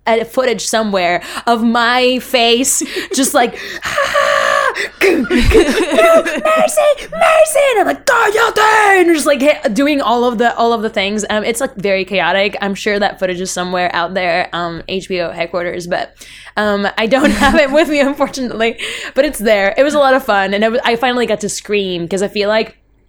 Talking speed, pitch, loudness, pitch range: 185 wpm, 235 Hz, -13 LUFS, 200-290 Hz